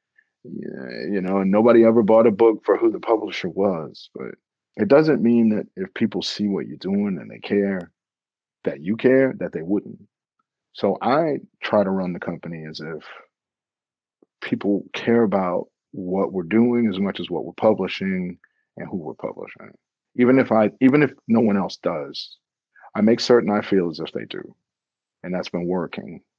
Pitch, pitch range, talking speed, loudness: 110 Hz, 95-120 Hz, 185 wpm, -21 LUFS